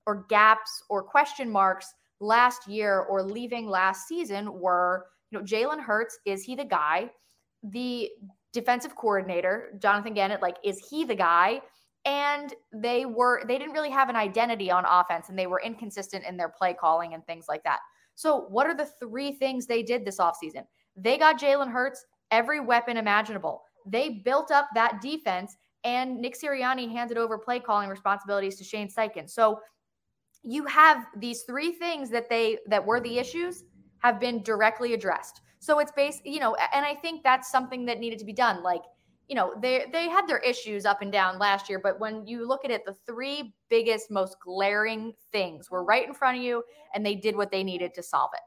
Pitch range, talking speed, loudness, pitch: 200-255 Hz, 195 wpm, -27 LUFS, 225 Hz